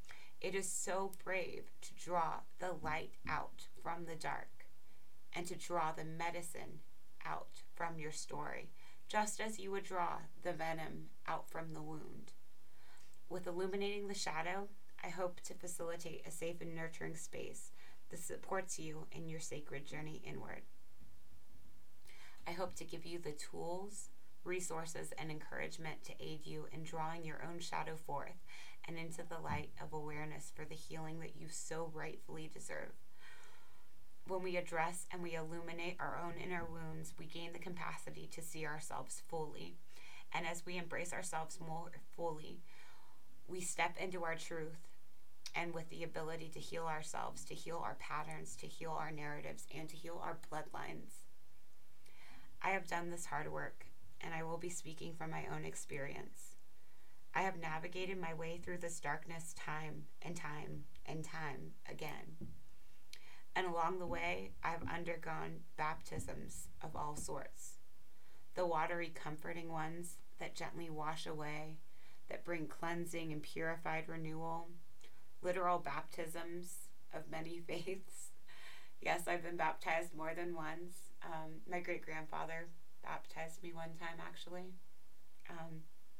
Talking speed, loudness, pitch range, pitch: 145 wpm, -45 LUFS, 155-175 Hz, 165 Hz